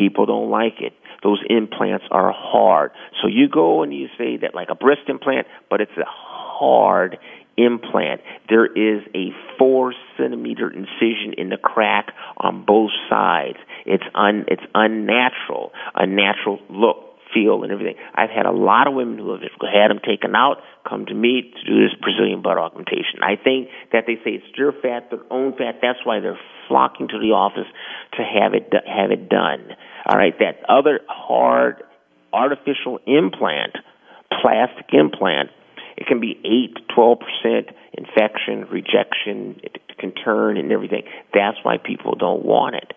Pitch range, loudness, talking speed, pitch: 110-130 Hz, -19 LUFS, 165 wpm, 120 Hz